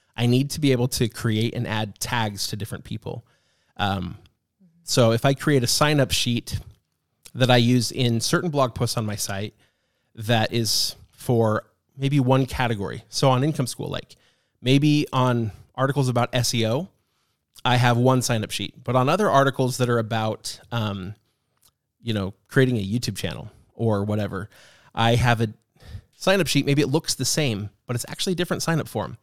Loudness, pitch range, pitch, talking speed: -23 LUFS, 110-135 Hz, 120 Hz, 175 wpm